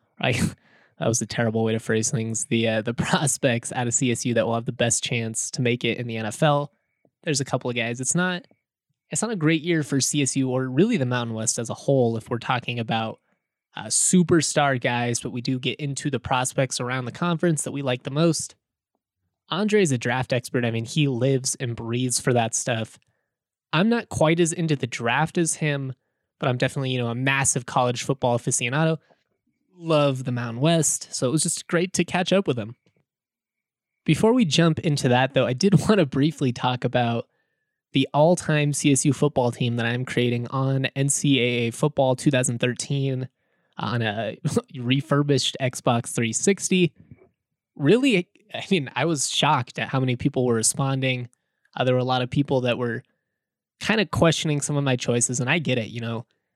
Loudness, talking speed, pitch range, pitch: -23 LUFS, 195 wpm, 120-150 Hz, 130 Hz